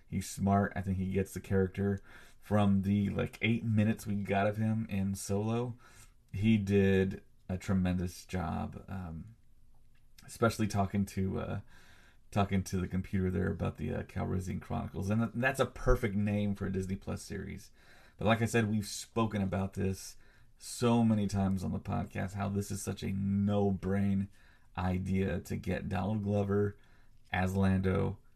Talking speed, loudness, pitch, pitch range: 160 wpm, -33 LUFS, 100 Hz, 95-110 Hz